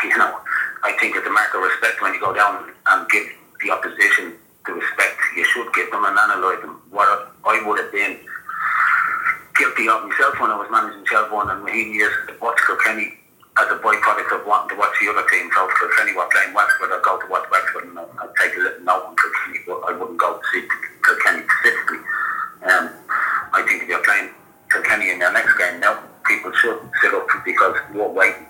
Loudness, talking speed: -18 LUFS, 205 wpm